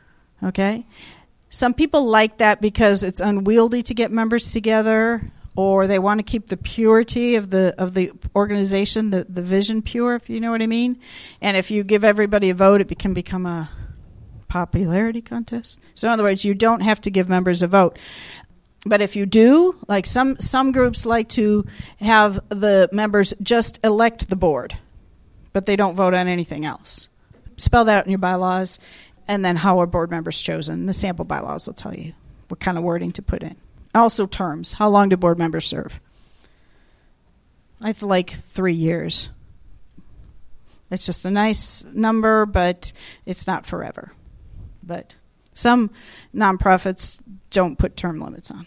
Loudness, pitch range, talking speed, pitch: -19 LUFS, 180-220 Hz, 170 wpm, 200 Hz